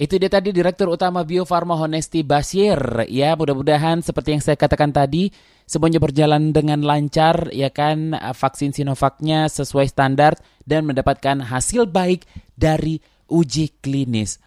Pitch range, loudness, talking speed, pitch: 140-165 Hz, -18 LUFS, 135 wpm, 150 Hz